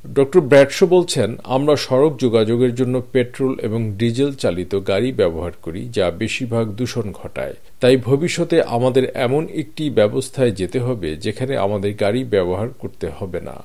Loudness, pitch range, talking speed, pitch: -18 LUFS, 110-135 Hz, 145 wpm, 125 Hz